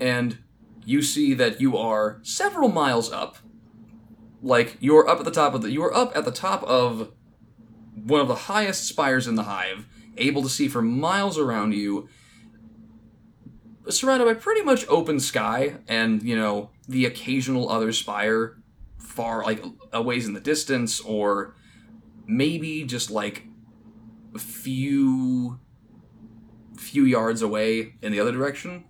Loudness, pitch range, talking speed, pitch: -23 LUFS, 110-140 Hz, 145 wpm, 115 Hz